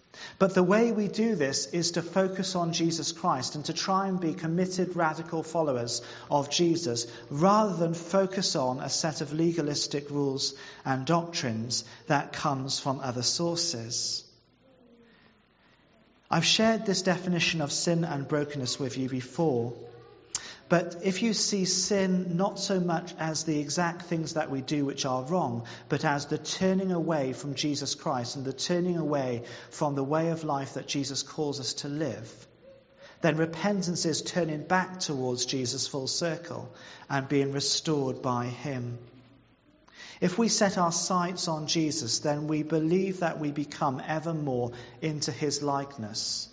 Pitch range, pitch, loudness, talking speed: 135-175 Hz, 155 Hz, -29 LUFS, 155 wpm